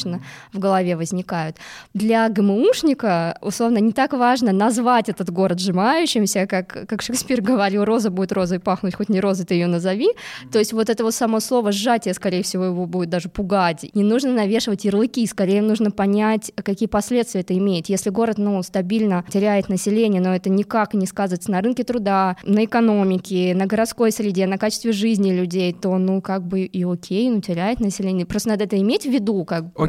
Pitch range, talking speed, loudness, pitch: 185-225 Hz, 185 wpm, -20 LUFS, 200 Hz